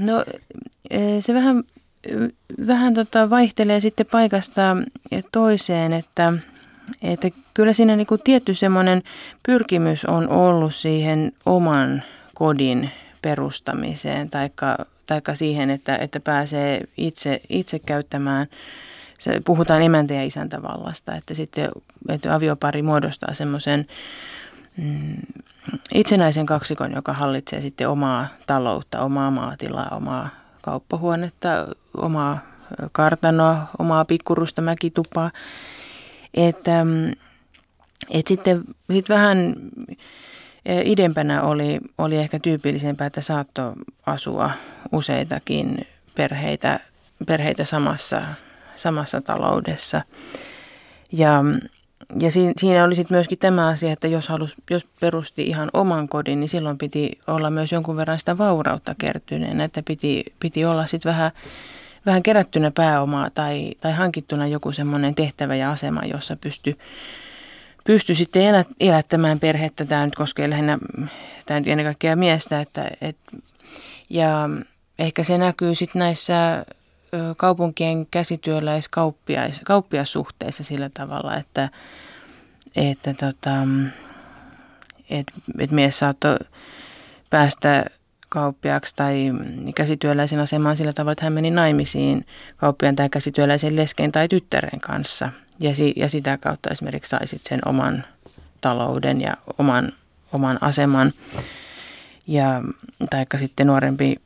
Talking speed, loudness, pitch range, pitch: 110 wpm, -21 LUFS, 145-175 Hz, 155 Hz